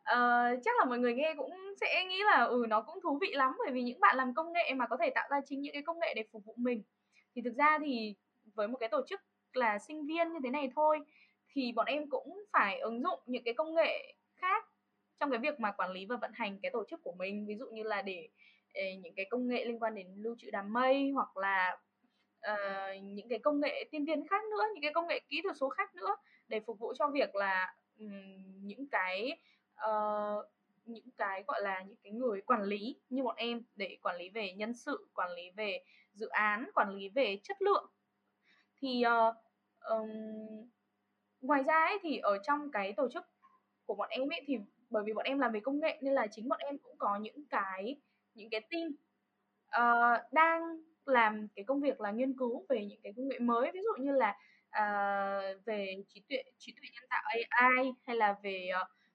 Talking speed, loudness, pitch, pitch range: 225 wpm, -34 LUFS, 245 Hz, 210-295 Hz